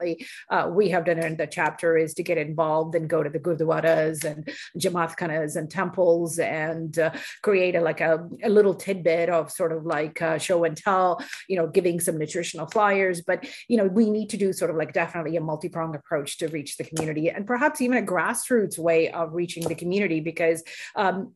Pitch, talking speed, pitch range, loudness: 170 Hz, 200 wpm, 160-185 Hz, -24 LUFS